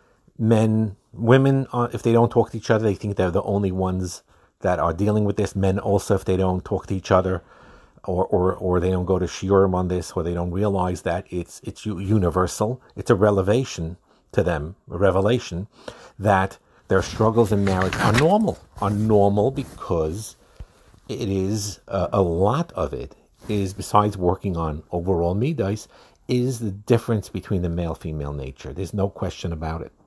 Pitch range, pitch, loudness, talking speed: 90-110 Hz, 100 Hz, -22 LUFS, 185 wpm